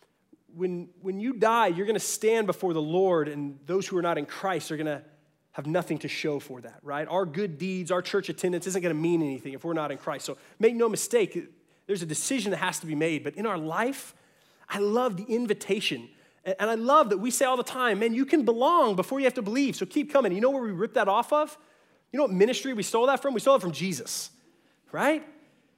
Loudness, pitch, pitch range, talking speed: -27 LUFS, 195 Hz, 165-250 Hz, 240 wpm